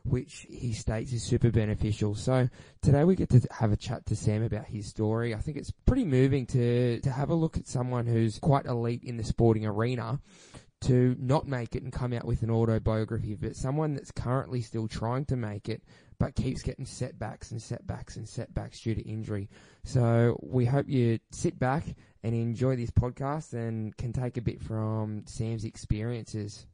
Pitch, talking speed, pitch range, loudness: 120 Hz, 195 wpm, 110-130 Hz, -30 LUFS